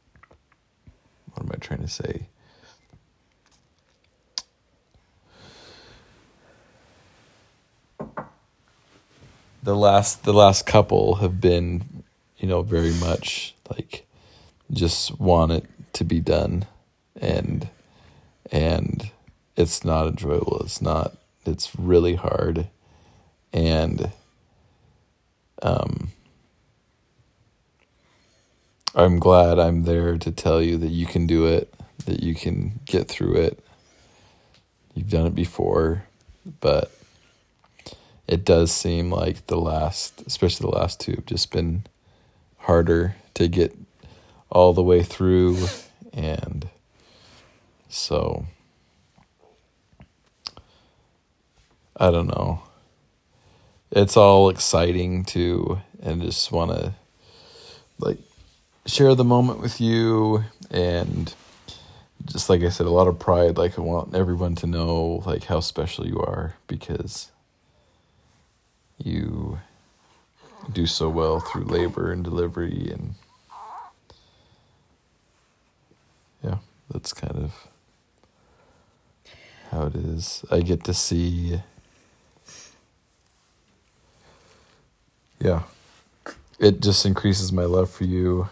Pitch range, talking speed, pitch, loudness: 85-95 Hz, 100 wpm, 90 Hz, -22 LUFS